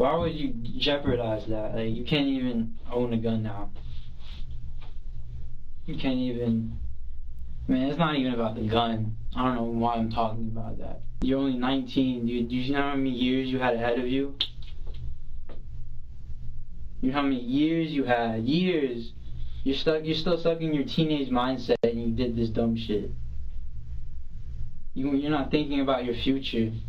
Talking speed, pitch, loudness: 170 wpm, 115 Hz, -27 LUFS